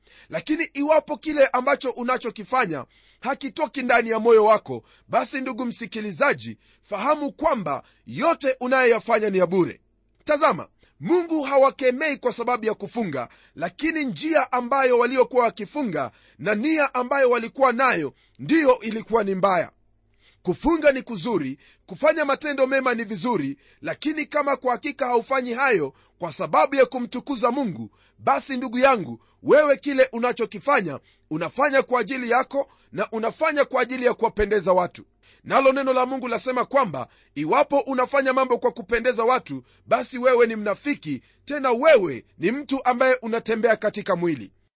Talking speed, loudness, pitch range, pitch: 135 wpm, -22 LUFS, 220-275 Hz, 250 Hz